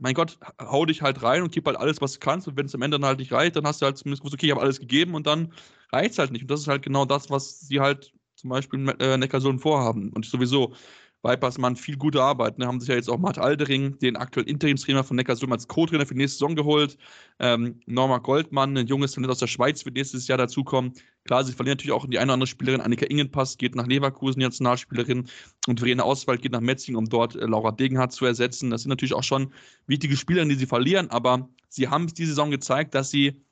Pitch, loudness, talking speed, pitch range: 135 Hz, -24 LUFS, 255 wpm, 125-140 Hz